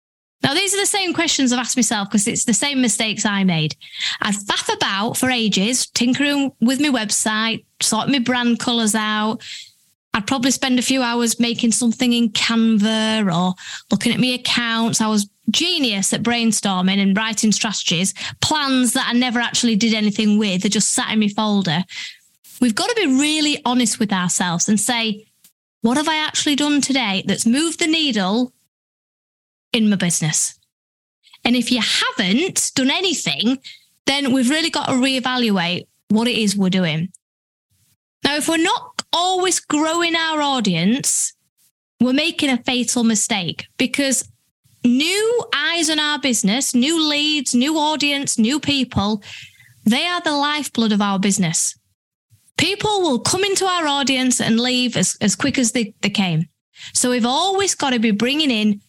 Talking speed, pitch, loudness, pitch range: 165 wpm, 240 Hz, -18 LUFS, 215-285 Hz